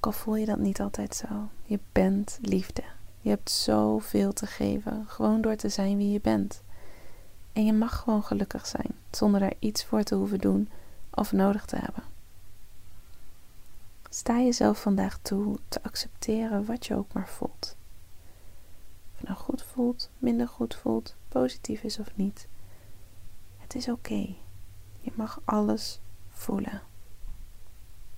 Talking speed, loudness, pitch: 150 wpm, -29 LUFS, 105 Hz